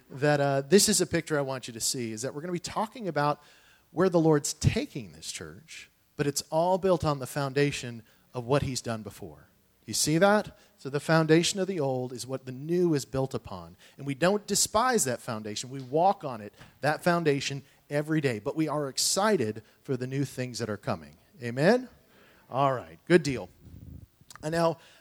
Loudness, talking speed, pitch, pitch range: -28 LUFS, 205 wpm, 140 Hz, 125-165 Hz